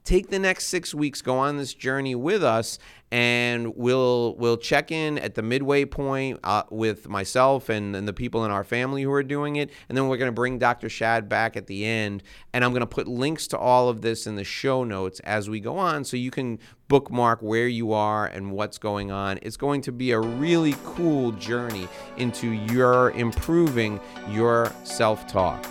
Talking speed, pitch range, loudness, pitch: 205 wpm, 110-135 Hz, -24 LUFS, 120 Hz